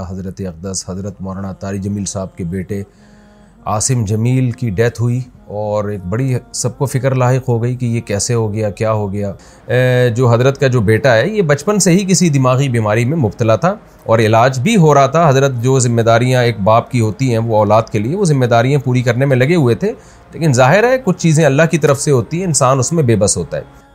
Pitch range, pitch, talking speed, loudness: 110-140 Hz, 125 Hz, 230 wpm, -13 LUFS